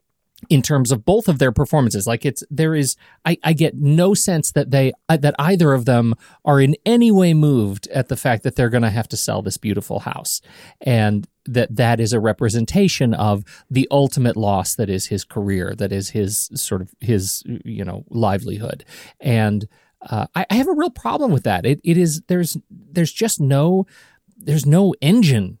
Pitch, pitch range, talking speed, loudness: 130 Hz, 110-160 Hz, 190 wpm, -18 LUFS